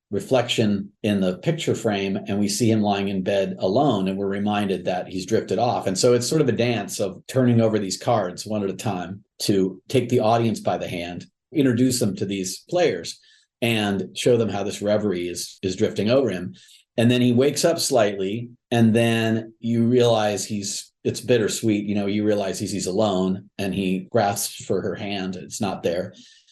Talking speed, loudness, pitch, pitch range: 200 wpm, -22 LUFS, 105 Hz, 100-115 Hz